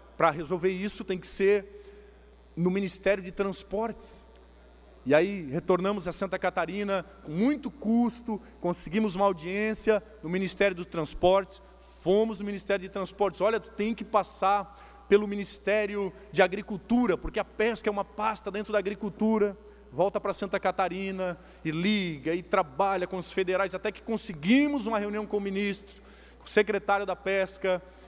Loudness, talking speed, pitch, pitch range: -29 LUFS, 155 wpm, 200 Hz, 185-210 Hz